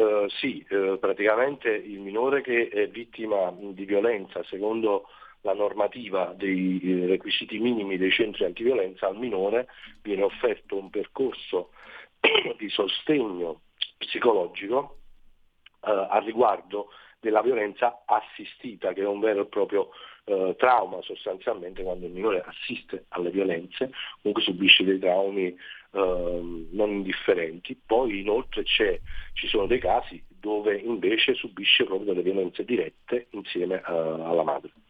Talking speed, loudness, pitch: 125 wpm, -26 LUFS, 115 Hz